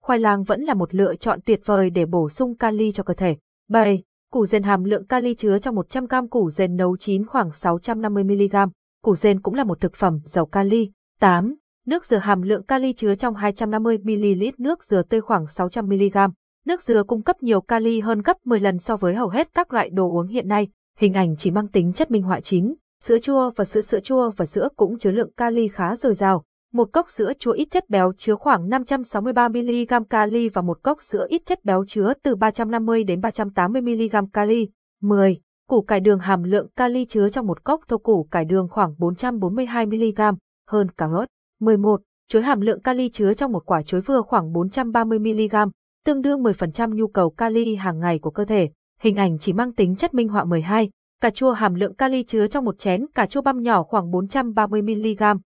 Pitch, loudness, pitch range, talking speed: 215 Hz, -21 LUFS, 195-240 Hz, 210 wpm